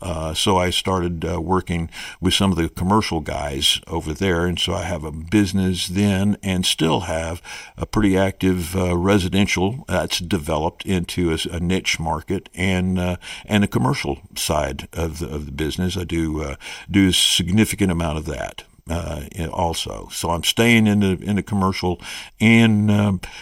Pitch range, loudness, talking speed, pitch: 85-100 Hz, -20 LUFS, 175 wpm, 90 Hz